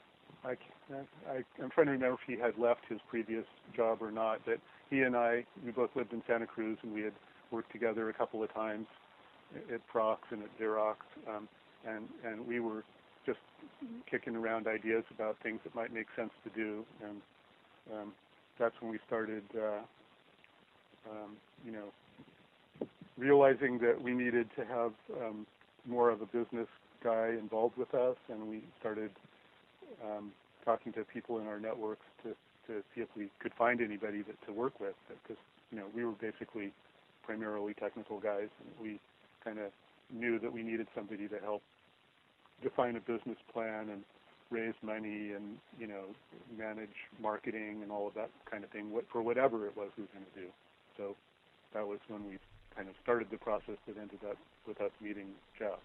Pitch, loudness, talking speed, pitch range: 110 Hz, -38 LUFS, 180 wpm, 105-115 Hz